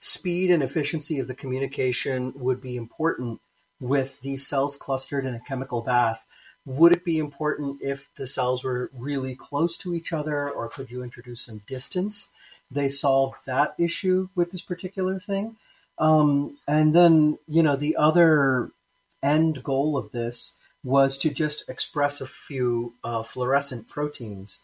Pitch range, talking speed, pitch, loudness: 130-155 Hz, 155 wpm, 140 Hz, -24 LUFS